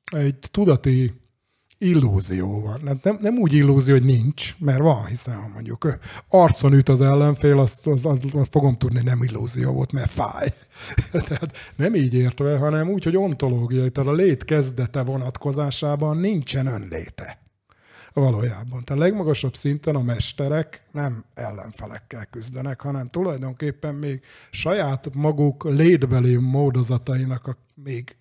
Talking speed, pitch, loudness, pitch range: 135 wpm, 135 Hz, -21 LUFS, 125-145 Hz